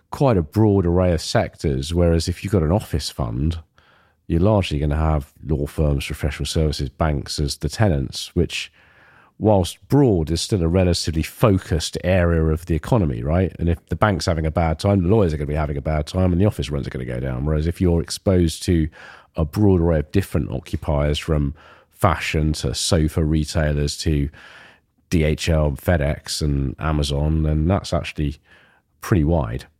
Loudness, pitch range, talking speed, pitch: -21 LUFS, 75-90 Hz, 185 wpm, 80 Hz